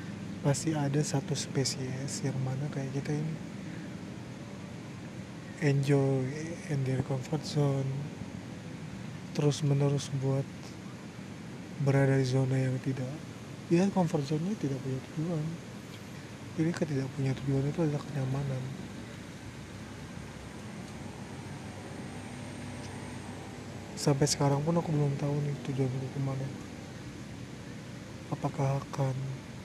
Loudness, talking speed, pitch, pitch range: -33 LUFS, 95 wpm, 140 Hz, 130-150 Hz